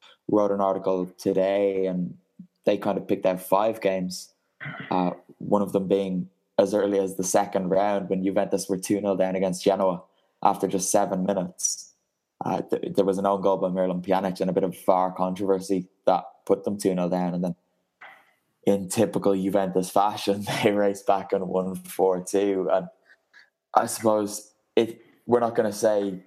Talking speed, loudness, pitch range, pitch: 175 wpm, -25 LUFS, 95-100 Hz, 95 Hz